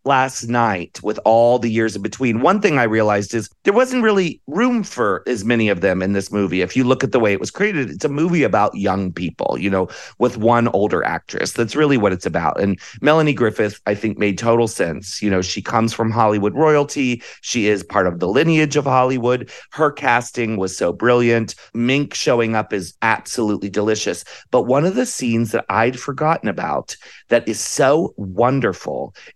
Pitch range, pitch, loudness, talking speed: 105-135 Hz, 115 Hz, -18 LUFS, 200 wpm